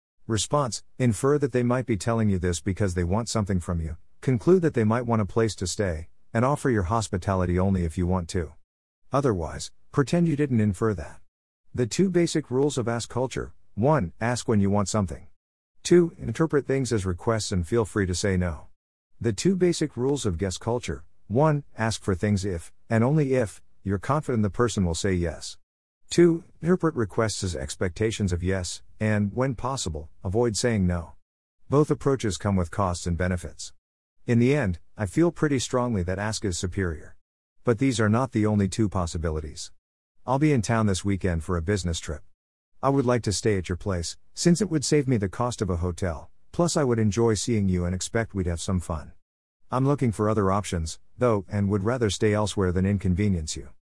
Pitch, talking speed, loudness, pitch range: 105 Hz, 200 wpm, -25 LUFS, 90-120 Hz